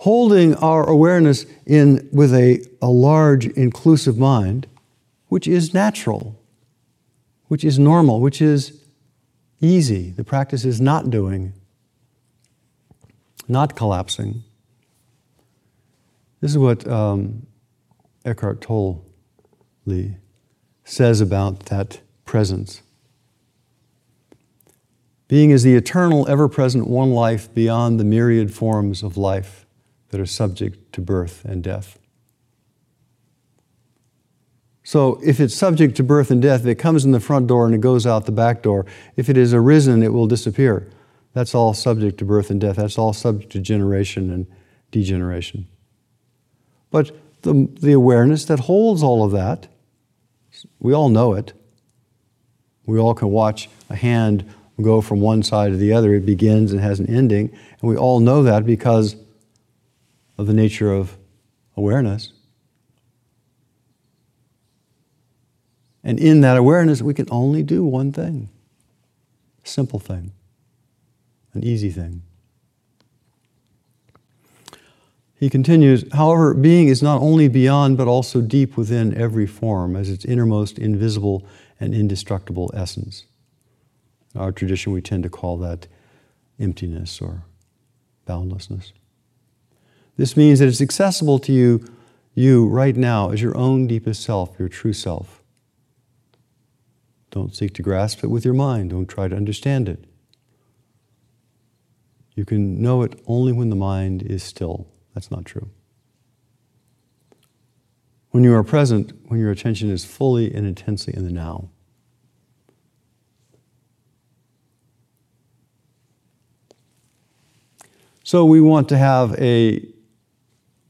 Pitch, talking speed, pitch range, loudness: 120 Hz, 125 wpm, 105-130 Hz, -17 LUFS